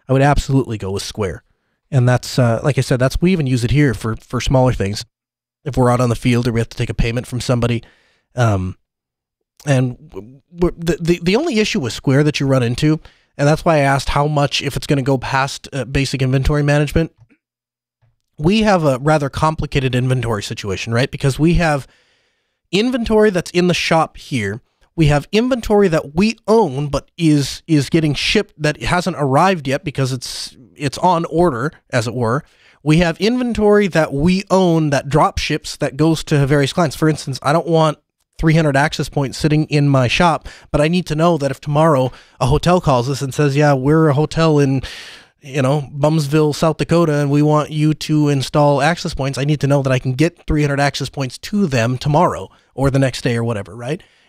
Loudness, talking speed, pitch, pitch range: -16 LUFS, 205 wpm, 145 Hz, 130-160 Hz